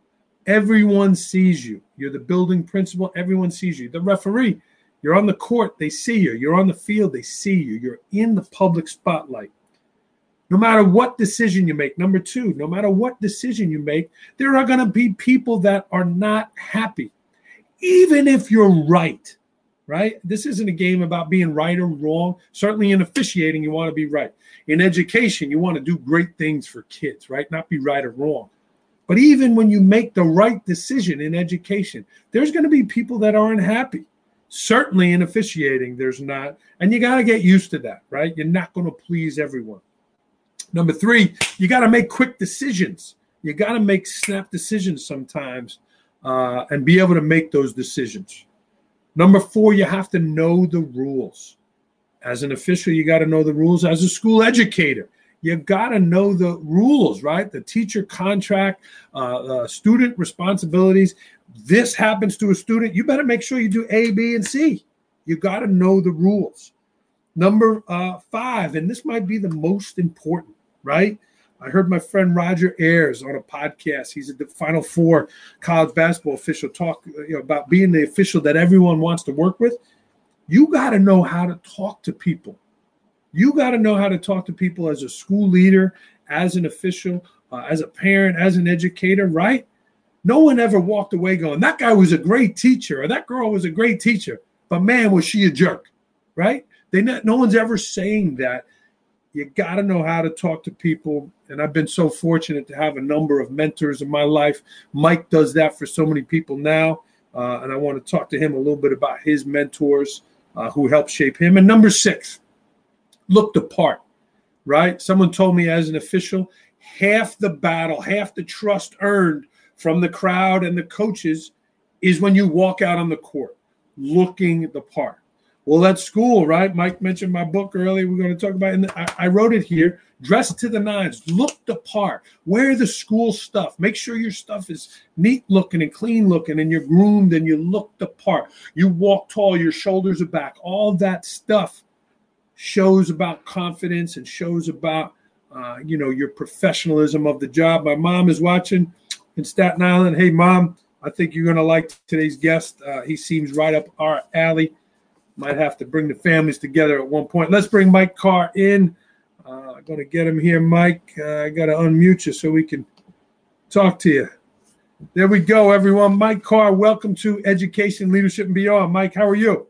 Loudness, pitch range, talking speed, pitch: -18 LUFS, 160-210 Hz, 195 wpm, 185 Hz